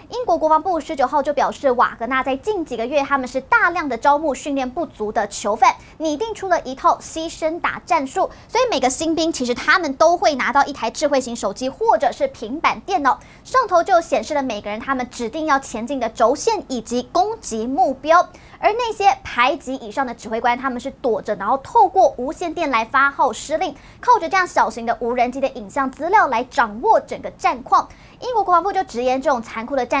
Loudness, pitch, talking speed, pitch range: -19 LUFS, 285 Hz, 325 characters per minute, 245-345 Hz